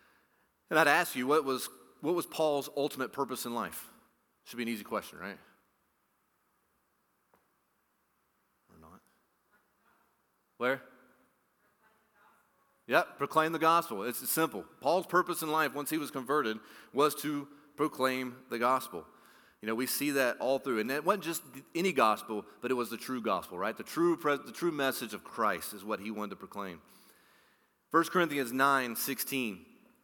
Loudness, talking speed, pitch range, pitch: -32 LUFS, 155 wpm, 125-155 Hz, 135 Hz